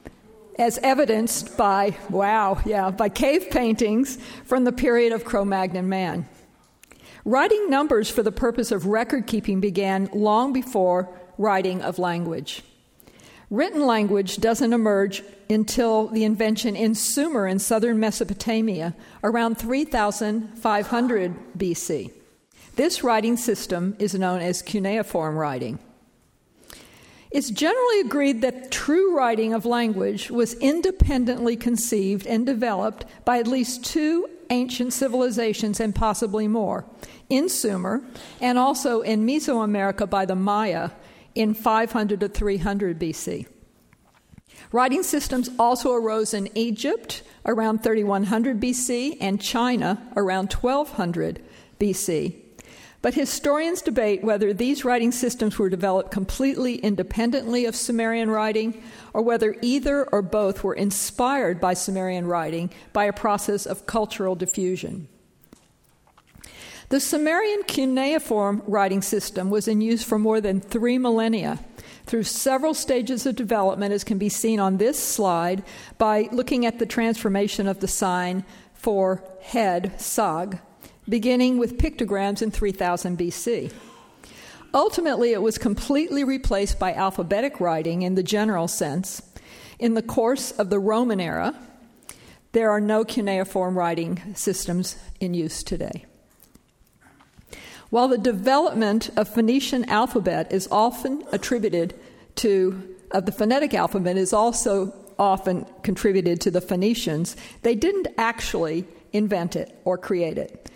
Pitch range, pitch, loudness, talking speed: 195-245 Hz, 220 Hz, -23 LUFS, 125 wpm